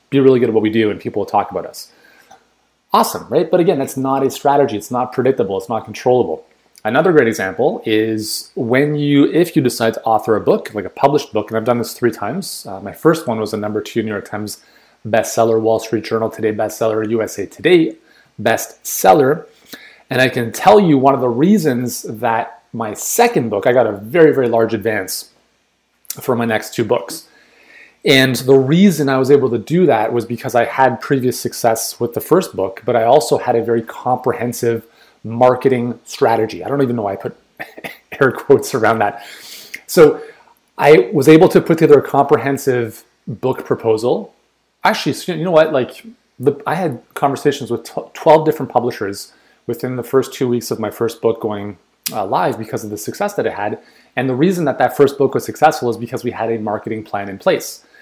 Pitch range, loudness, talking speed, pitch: 115-140 Hz, -16 LUFS, 200 wpm, 125 Hz